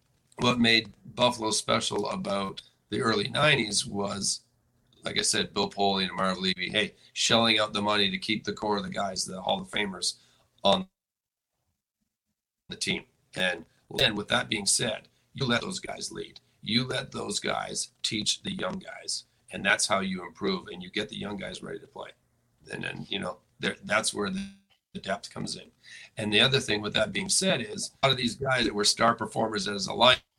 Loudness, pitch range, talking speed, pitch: -27 LUFS, 100-125 Hz, 195 wpm, 110 Hz